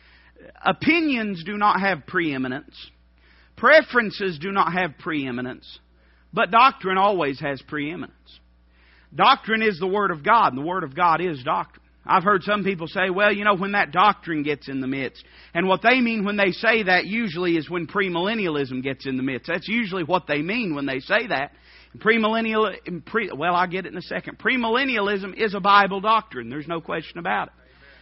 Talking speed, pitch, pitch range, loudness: 190 wpm, 185 Hz, 140-210 Hz, -21 LUFS